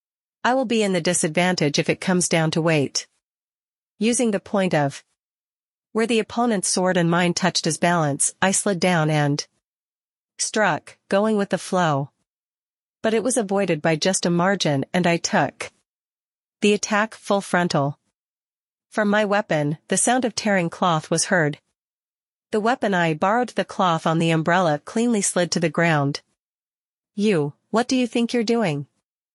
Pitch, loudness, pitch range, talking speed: 185 Hz, -21 LUFS, 165-215 Hz, 165 wpm